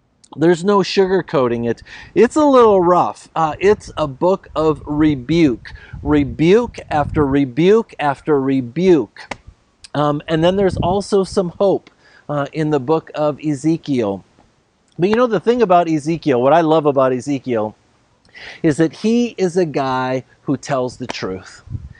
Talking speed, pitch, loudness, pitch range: 145 wpm, 155 Hz, -16 LUFS, 130-180 Hz